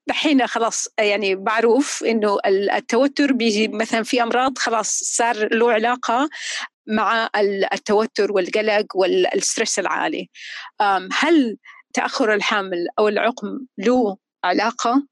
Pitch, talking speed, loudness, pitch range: 225 Hz, 105 wpm, -19 LUFS, 210-245 Hz